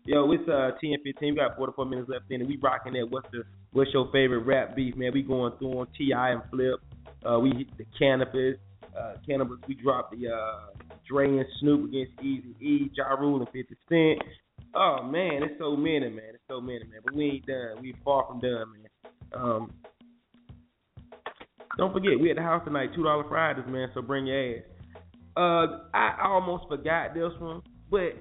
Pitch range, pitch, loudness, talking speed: 125-150 Hz, 135 Hz, -28 LUFS, 200 wpm